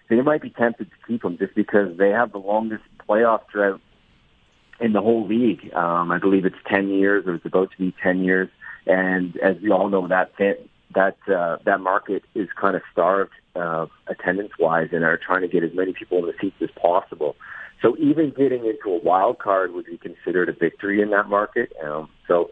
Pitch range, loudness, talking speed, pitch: 95-120 Hz, -22 LUFS, 210 wpm, 100 Hz